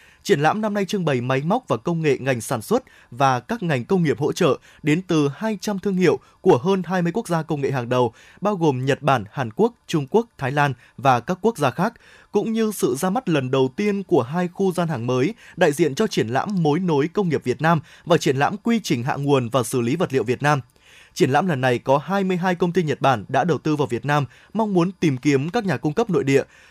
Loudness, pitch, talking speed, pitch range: -21 LUFS, 160 Hz, 260 wpm, 135-195 Hz